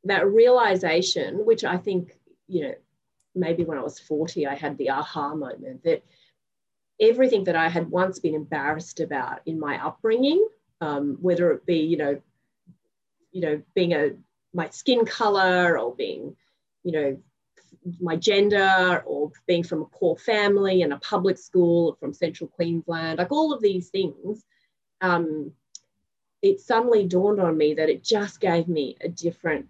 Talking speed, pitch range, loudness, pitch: 160 wpm, 160-205 Hz, -23 LUFS, 175 Hz